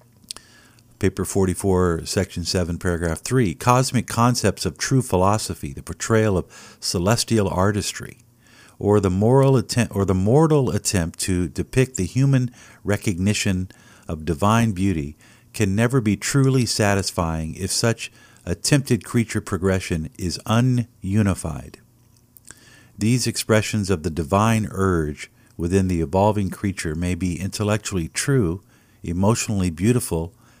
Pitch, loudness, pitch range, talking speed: 105 Hz, -21 LUFS, 95-120 Hz, 120 wpm